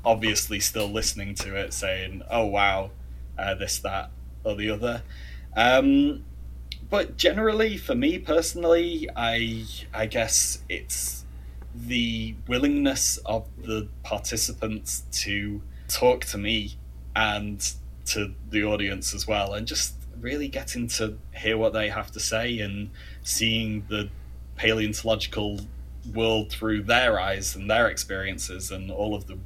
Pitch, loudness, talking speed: 105 Hz, -26 LUFS, 130 wpm